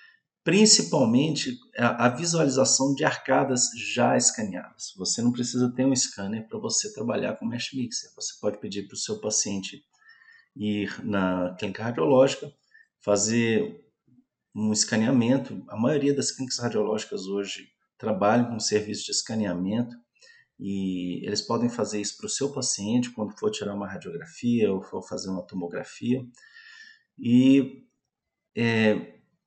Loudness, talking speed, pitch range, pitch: -25 LUFS, 135 wpm, 105-135 Hz, 120 Hz